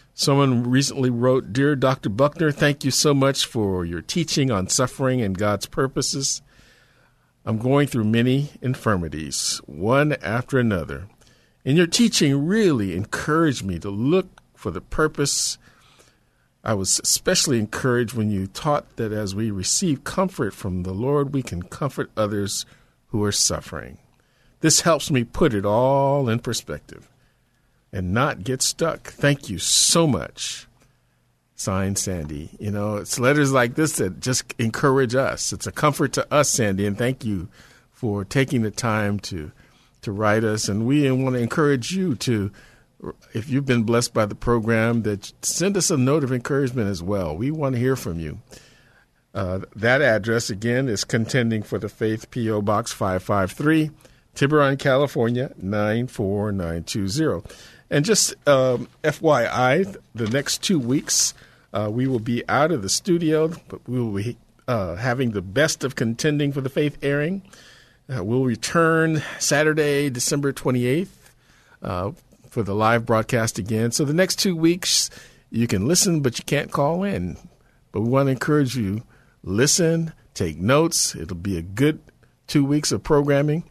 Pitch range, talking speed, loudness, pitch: 105-145 Hz, 160 wpm, -21 LUFS, 125 Hz